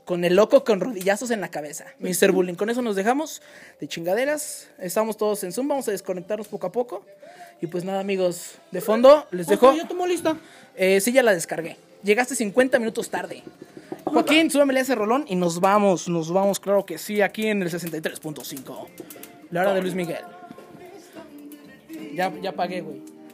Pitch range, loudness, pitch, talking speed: 180-260 Hz, -22 LUFS, 200 Hz, 180 wpm